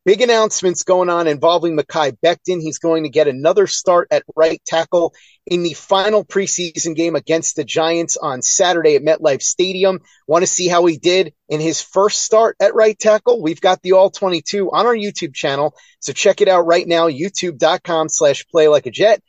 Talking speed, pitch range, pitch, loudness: 195 wpm, 160-195 Hz, 175 Hz, -15 LUFS